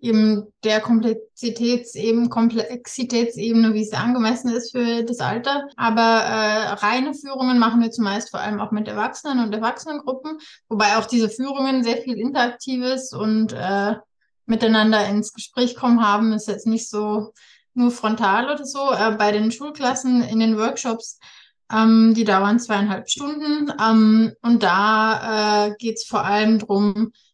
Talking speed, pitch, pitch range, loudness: 150 wpm, 225 Hz, 215-245 Hz, -20 LUFS